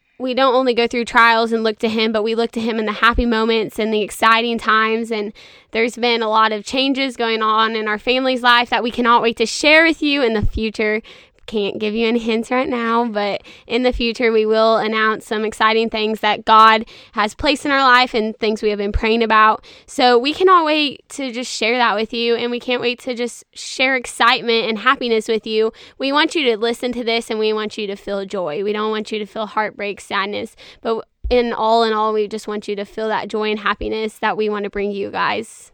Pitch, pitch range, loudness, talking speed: 225 Hz, 215-240 Hz, -17 LUFS, 240 wpm